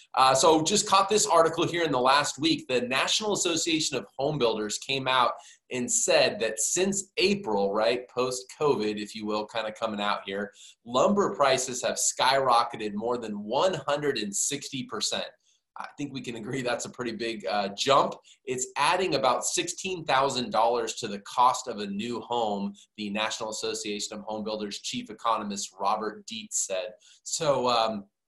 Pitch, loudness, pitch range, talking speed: 125 Hz, -27 LUFS, 105-160 Hz, 165 wpm